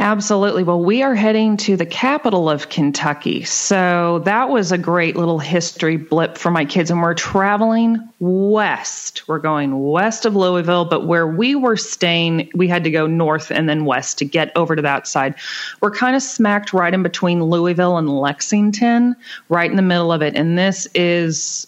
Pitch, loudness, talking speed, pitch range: 175 Hz, -17 LUFS, 190 wpm, 160-205 Hz